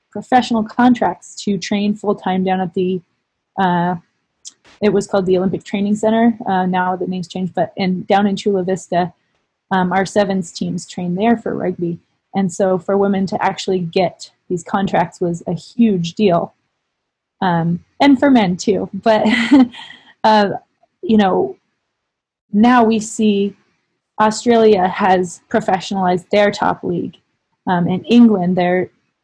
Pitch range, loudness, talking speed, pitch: 185-215 Hz, -16 LUFS, 145 wpm, 195 Hz